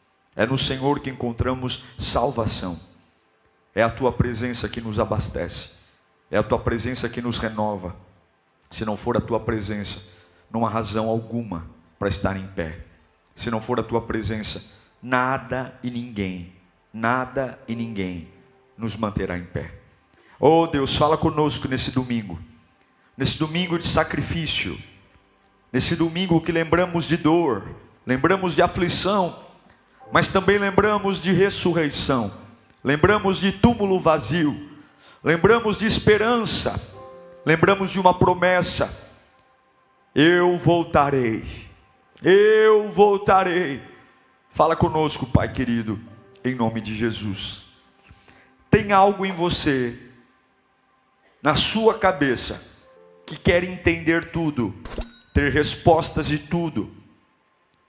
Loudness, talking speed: -21 LUFS, 115 wpm